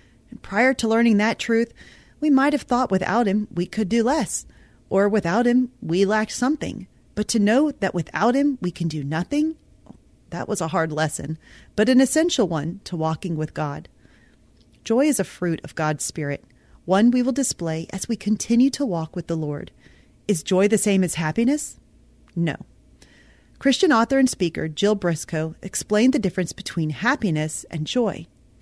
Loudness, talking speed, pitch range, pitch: -22 LUFS, 175 wpm, 160-235 Hz, 195 Hz